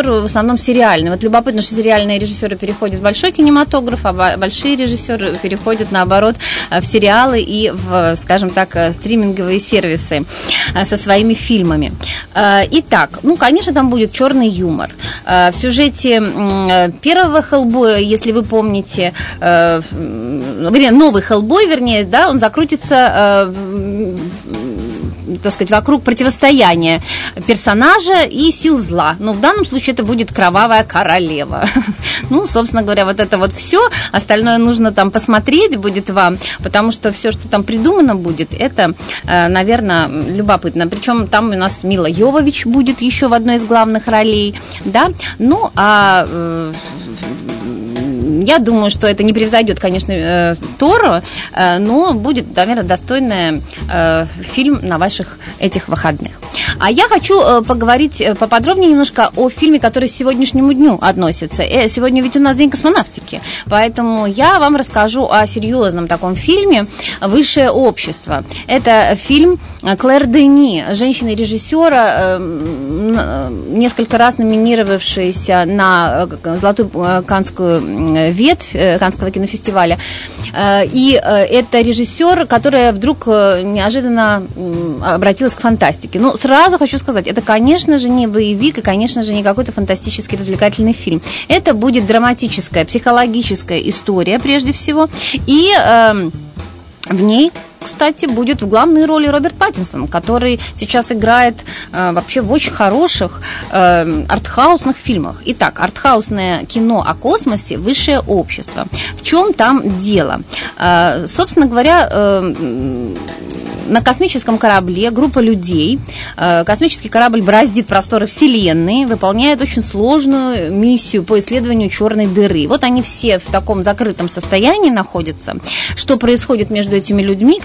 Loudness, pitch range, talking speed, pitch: -11 LUFS, 190-260 Hz, 125 wpm, 220 Hz